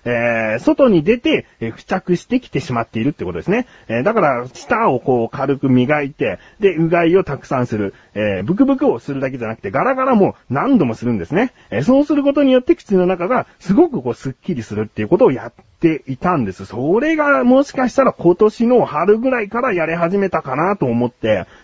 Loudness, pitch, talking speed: -16 LUFS, 165 Hz, 425 characters per minute